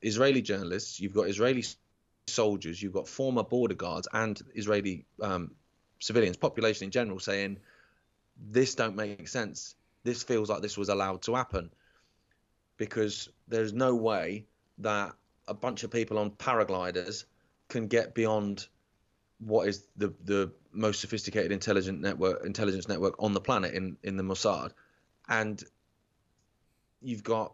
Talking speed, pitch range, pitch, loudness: 140 wpm, 100-115 Hz, 105 Hz, -31 LUFS